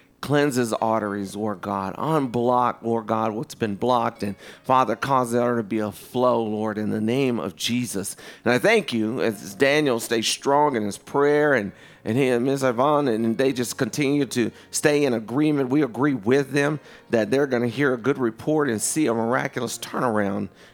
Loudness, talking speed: -23 LUFS, 195 wpm